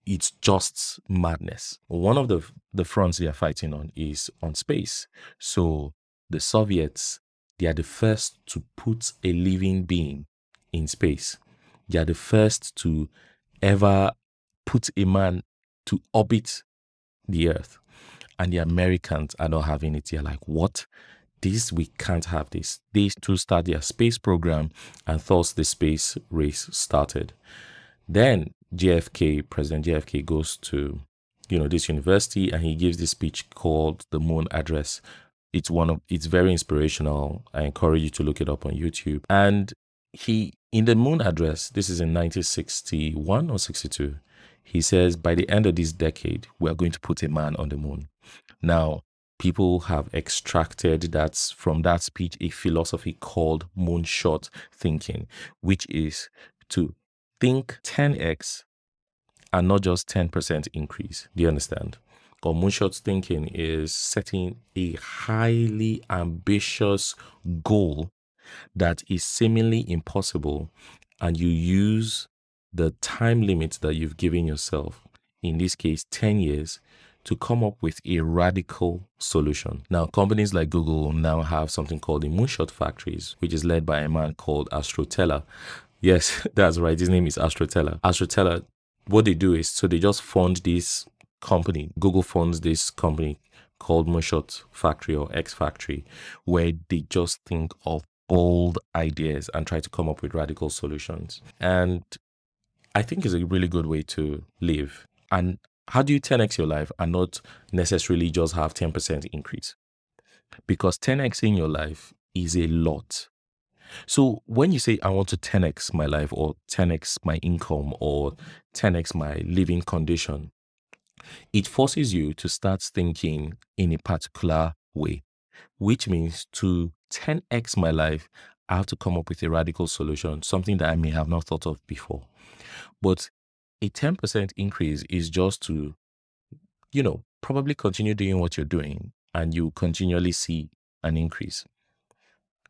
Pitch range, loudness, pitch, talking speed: 80-95 Hz, -25 LUFS, 85 Hz, 150 wpm